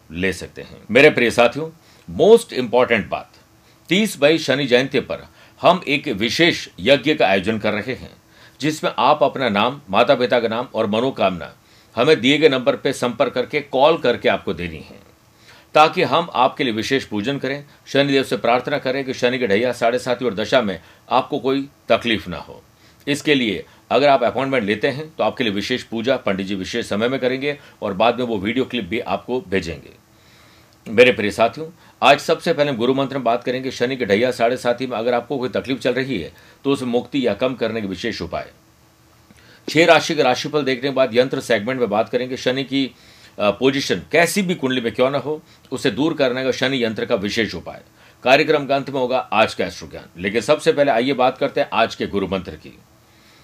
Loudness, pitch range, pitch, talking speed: -19 LUFS, 115-140 Hz, 125 Hz, 200 wpm